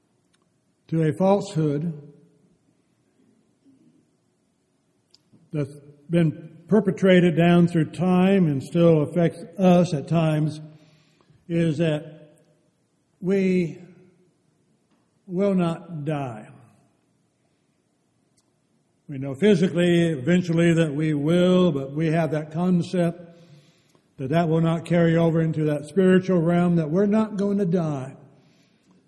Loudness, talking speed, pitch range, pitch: -22 LUFS, 100 wpm, 155-180 Hz, 165 Hz